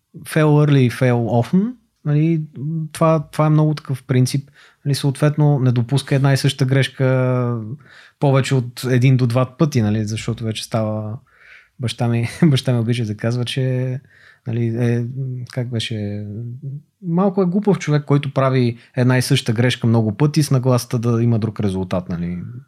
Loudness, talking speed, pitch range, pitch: -18 LUFS, 160 wpm, 120-145 Hz, 130 Hz